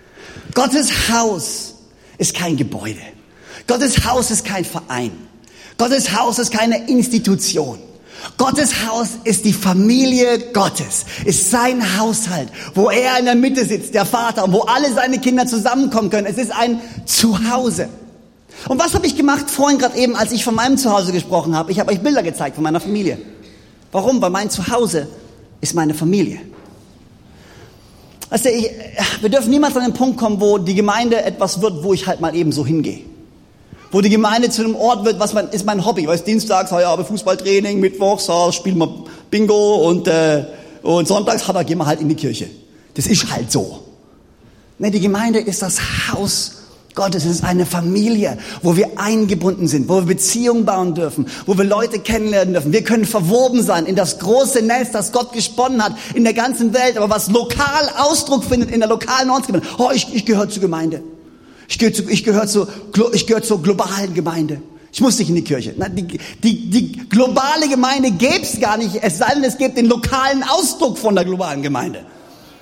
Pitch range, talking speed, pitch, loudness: 180-240 Hz, 190 wpm, 210 Hz, -16 LUFS